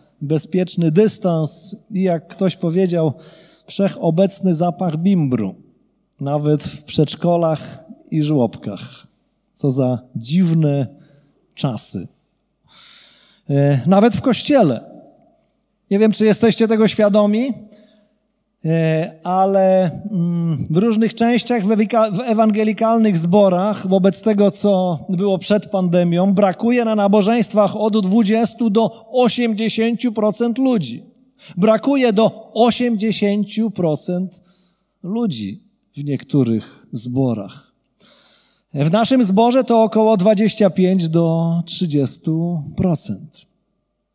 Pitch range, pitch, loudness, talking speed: 165-220 Hz, 195 Hz, -17 LUFS, 90 wpm